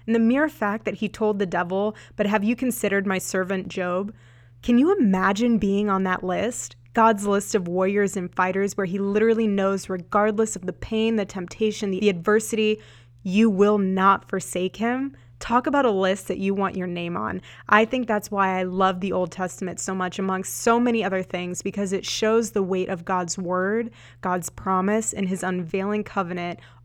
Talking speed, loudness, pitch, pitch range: 190 wpm, -23 LUFS, 195 Hz, 185-215 Hz